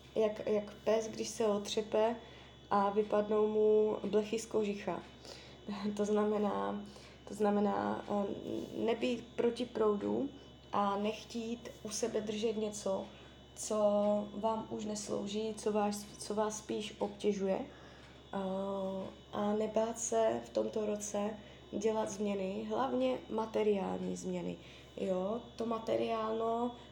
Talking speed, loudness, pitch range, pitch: 110 wpm, -36 LUFS, 200-220 Hz, 210 Hz